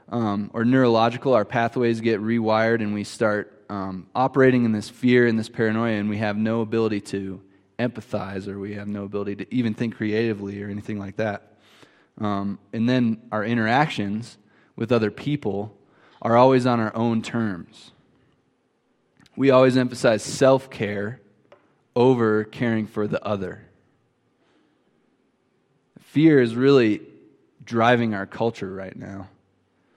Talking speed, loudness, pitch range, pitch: 140 wpm, -22 LUFS, 105-120 Hz, 110 Hz